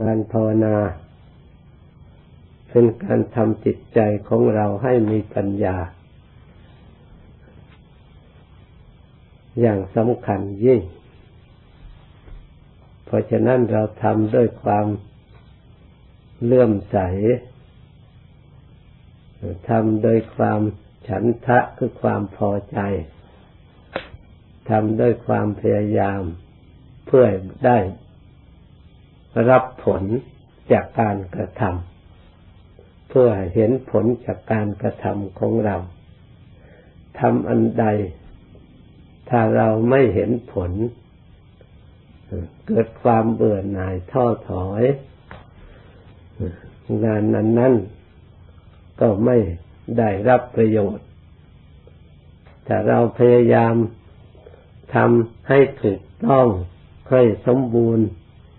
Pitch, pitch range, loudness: 105 Hz, 95-120 Hz, -19 LUFS